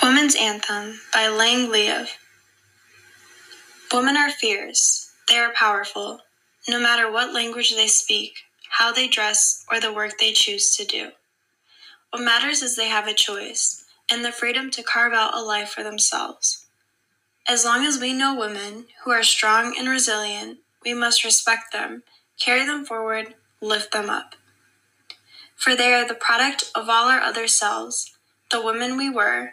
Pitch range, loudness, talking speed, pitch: 215-245 Hz, -19 LUFS, 160 wpm, 230 Hz